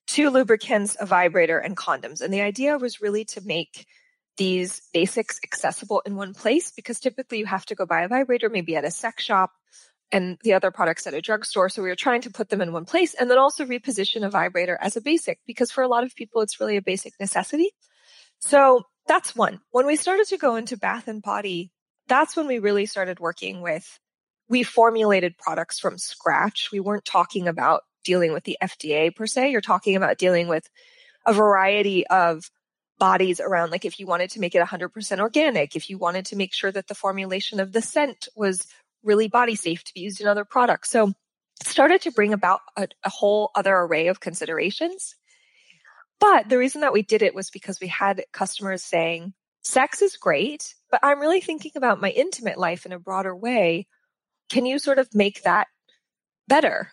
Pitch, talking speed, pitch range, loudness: 205 Hz, 200 wpm, 185-255 Hz, -22 LUFS